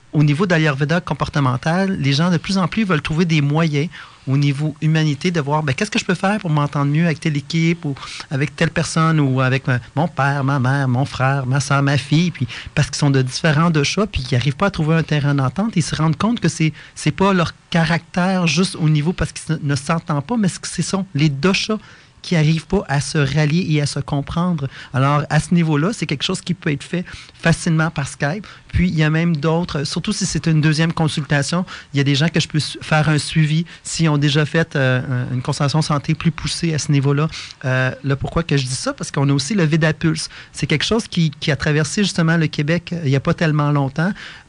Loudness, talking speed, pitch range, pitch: -18 LUFS, 245 wpm, 145-170 Hz, 155 Hz